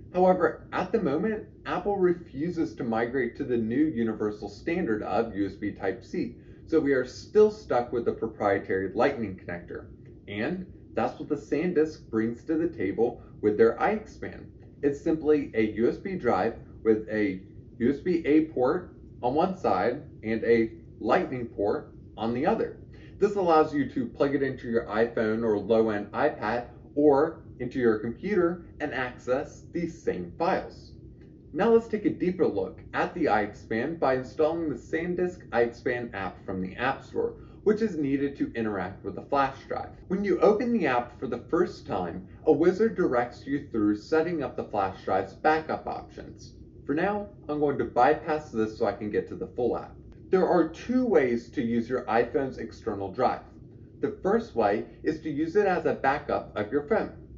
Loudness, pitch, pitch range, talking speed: -28 LUFS, 130 Hz, 110-155 Hz, 175 wpm